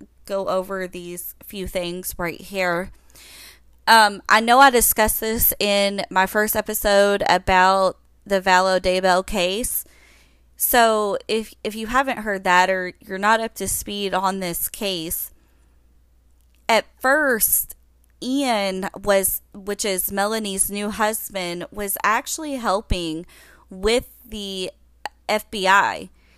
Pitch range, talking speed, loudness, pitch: 180-215 Hz, 120 wpm, -20 LUFS, 195 Hz